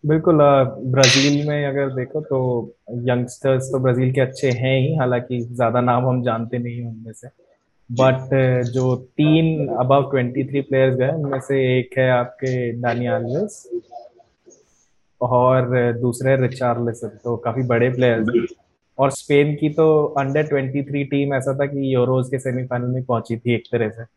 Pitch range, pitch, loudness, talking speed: 125-140 Hz, 130 Hz, -19 LUFS, 155 wpm